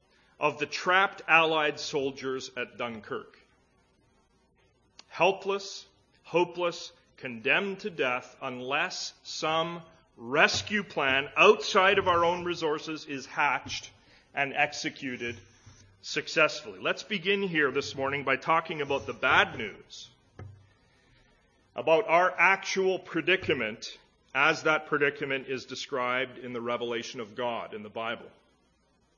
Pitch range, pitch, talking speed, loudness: 125-170 Hz, 150 Hz, 110 wpm, -28 LUFS